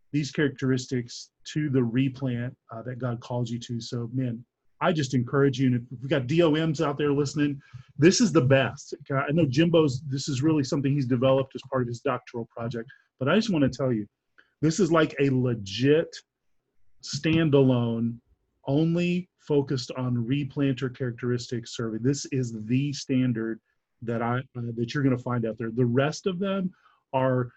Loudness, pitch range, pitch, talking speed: -26 LUFS, 120-145 Hz, 135 Hz, 180 wpm